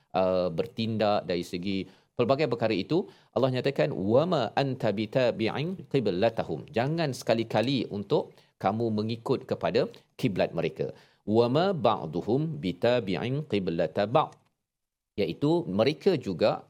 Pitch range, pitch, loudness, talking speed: 100-140 Hz, 115 Hz, -28 LUFS, 95 wpm